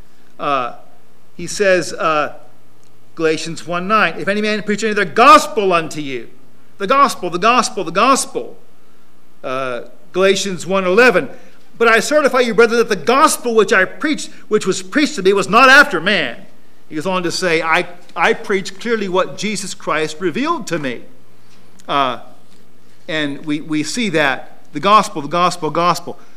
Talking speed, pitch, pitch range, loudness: 160 wpm, 185 Hz, 155-220 Hz, -15 LUFS